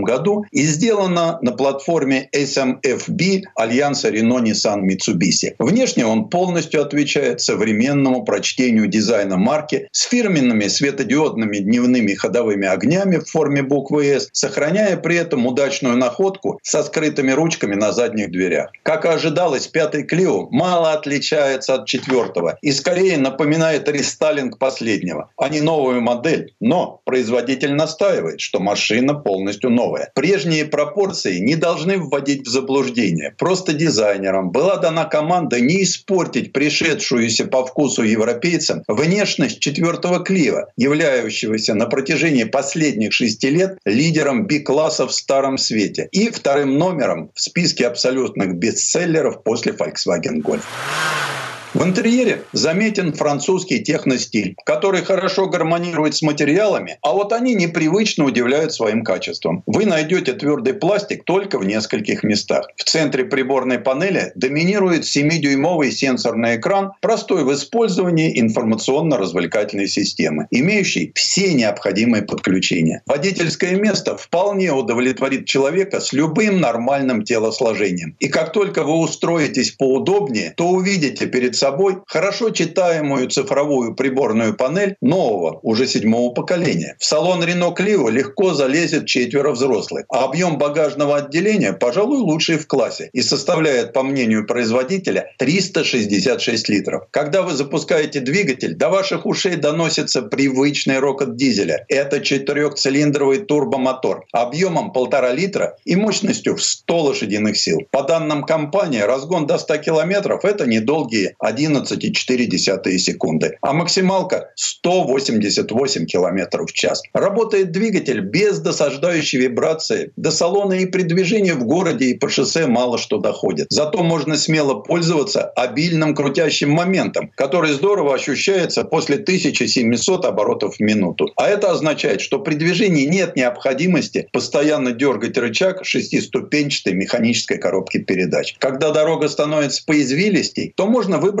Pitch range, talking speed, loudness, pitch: 135-185 Hz, 125 wpm, -17 LUFS, 150 Hz